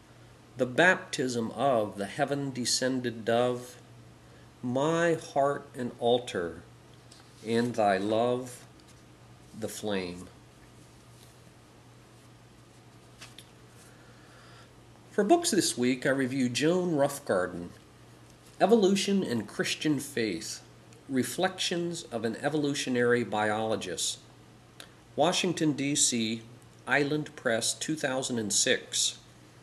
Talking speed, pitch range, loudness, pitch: 75 wpm, 105-145 Hz, -29 LUFS, 120 Hz